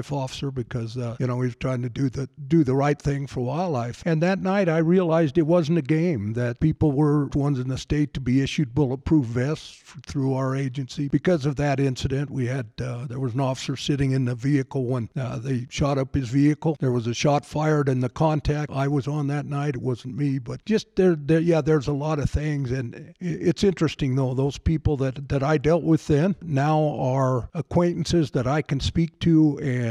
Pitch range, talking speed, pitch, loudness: 130-155 Hz, 220 wpm, 140 Hz, -24 LUFS